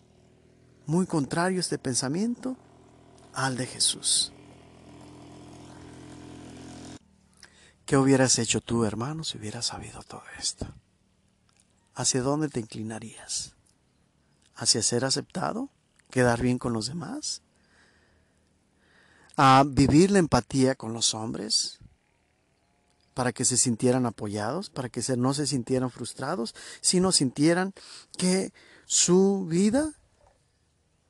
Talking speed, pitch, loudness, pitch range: 100 wpm, 130 Hz, -26 LUFS, 115-145 Hz